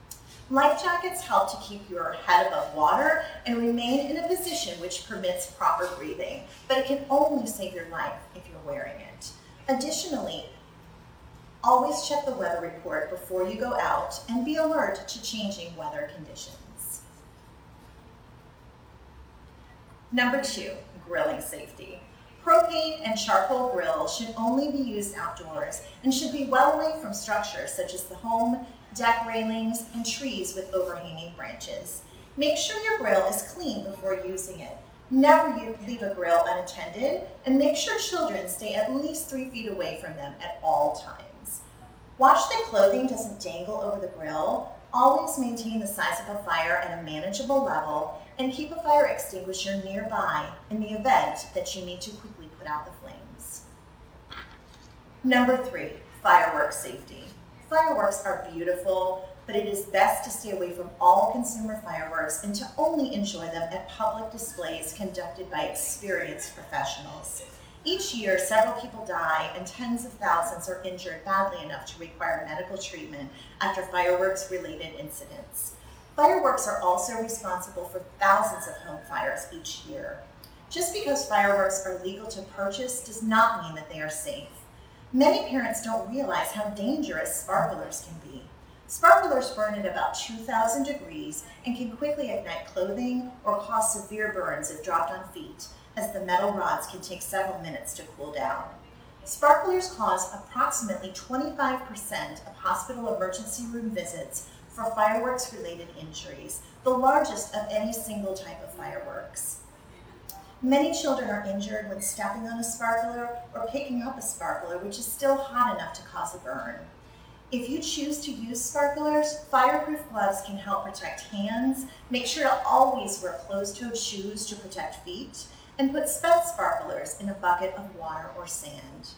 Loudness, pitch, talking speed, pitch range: -28 LUFS, 225 Hz, 155 wpm, 190-275 Hz